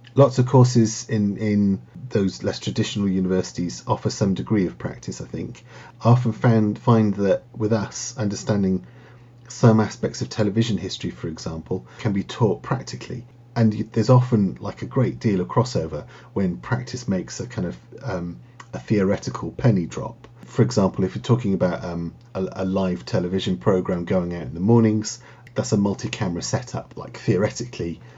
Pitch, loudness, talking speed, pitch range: 110 Hz, -23 LUFS, 165 wpm, 95-120 Hz